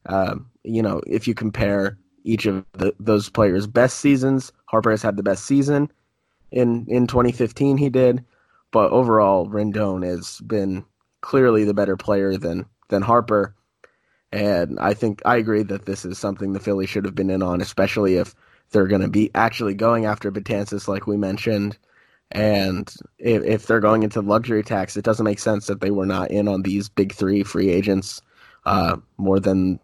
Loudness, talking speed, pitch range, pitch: -21 LUFS, 185 wpm, 95-110 Hz, 105 Hz